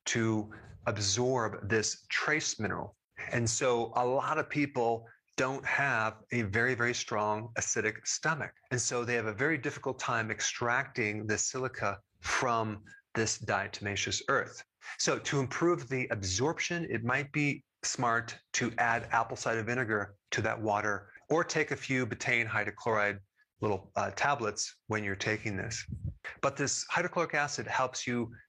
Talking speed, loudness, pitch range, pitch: 145 wpm, -32 LUFS, 105-130 Hz, 115 Hz